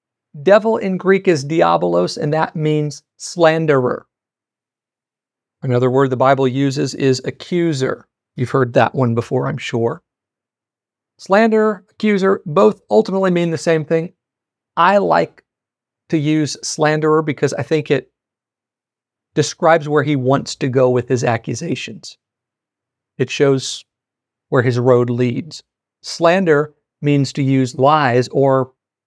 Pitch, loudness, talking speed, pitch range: 145 Hz, -16 LUFS, 125 wpm, 130-160 Hz